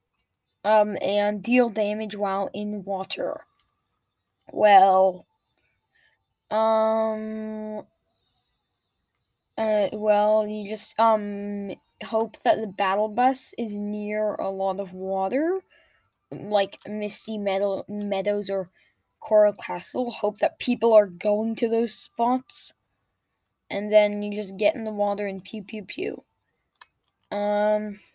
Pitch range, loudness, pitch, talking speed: 200-220 Hz, -24 LUFS, 210 Hz, 115 wpm